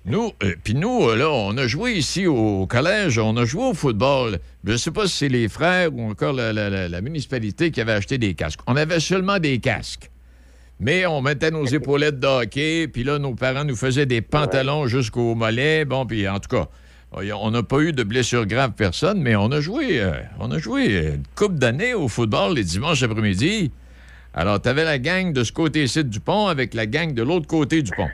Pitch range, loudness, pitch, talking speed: 105-150 Hz, -21 LUFS, 130 Hz, 225 wpm